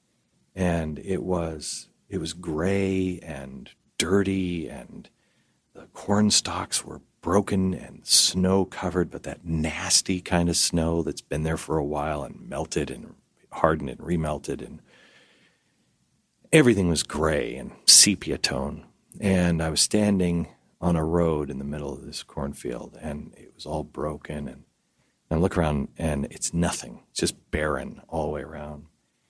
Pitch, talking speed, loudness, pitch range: 85 Hz, 155 wpm, -24 LUFS, 75-95 Hz